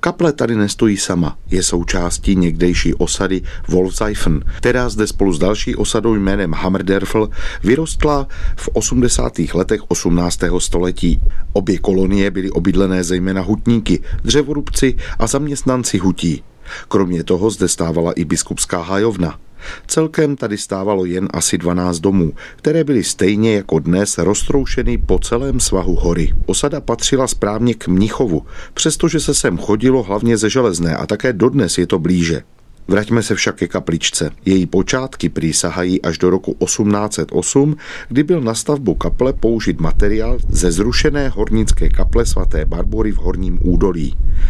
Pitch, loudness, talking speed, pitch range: 95 Hz, -16 LUFS, 140 wpm, 90-115 Hz